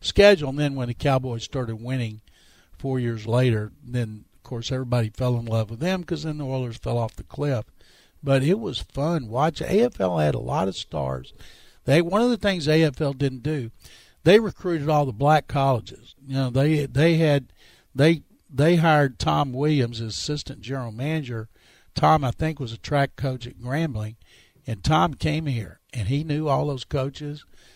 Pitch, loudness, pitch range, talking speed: 135 Hz, -24 LUFS, 120-155 Hz, 185 wpm